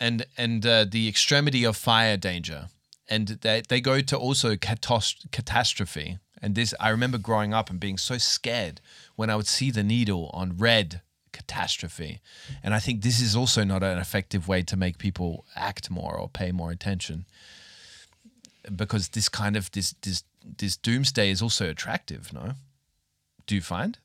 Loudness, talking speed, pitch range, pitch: -26 LUFS, 170 wpm, 95-115 Hz, 105 Hz